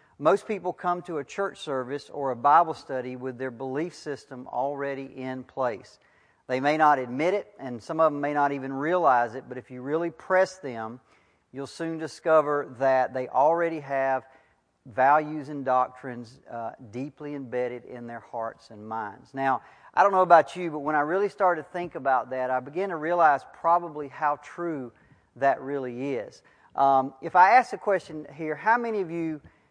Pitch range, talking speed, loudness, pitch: 130-165 Hz, 185 wpm, -26 LUFS, 145 Hz